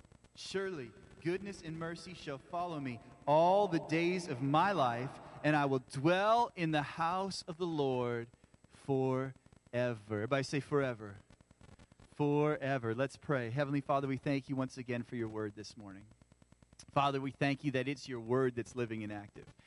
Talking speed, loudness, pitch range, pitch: 165 wpm, -35 LUFS, 115-150 Hz, 135 Hz